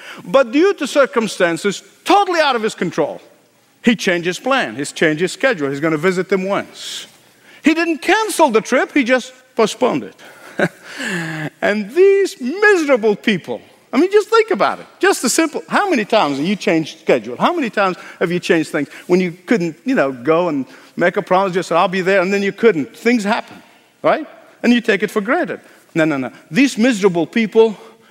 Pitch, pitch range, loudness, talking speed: 225 Hz, 185-285 Hz, -16 LUFS, 195 wpm